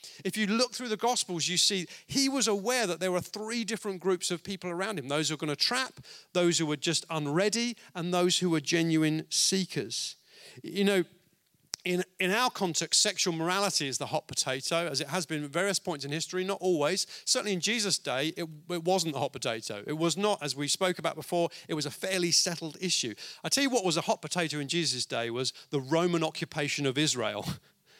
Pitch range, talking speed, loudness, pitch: 155-195 Hz, 220 wpm, -29 LUFS, 175 Hz